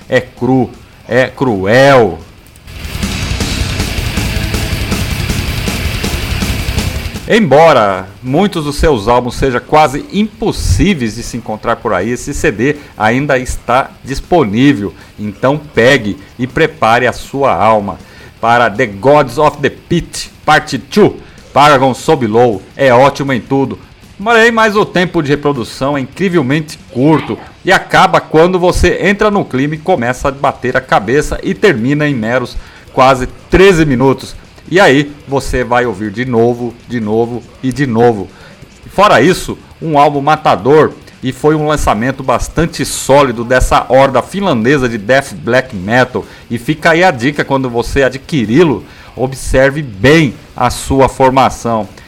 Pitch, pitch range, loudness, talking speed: 125 Hz, 110-145 Hz, -11 LUFS, 130 wpm